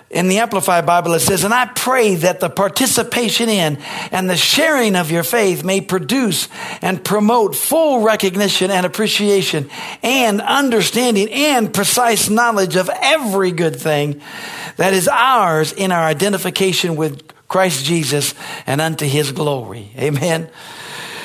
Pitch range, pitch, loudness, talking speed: 165-220 Hz, 190 Hz, -15 LUFS, 140 wpm